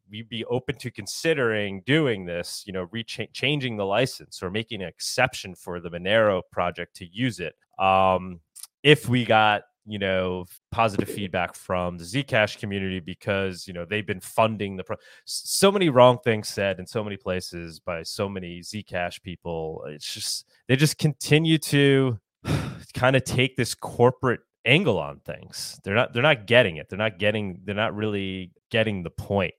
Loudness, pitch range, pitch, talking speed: -24 LUFS, 95-125 Hz, 105 Hz, 175 wpm